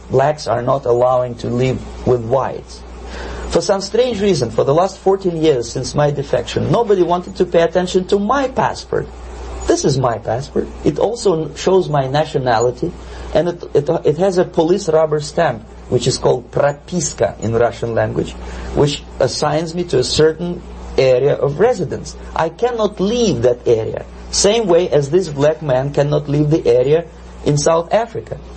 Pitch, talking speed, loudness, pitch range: 155 Hz, 170 wpm, -16 LUFS, 125-185 Hz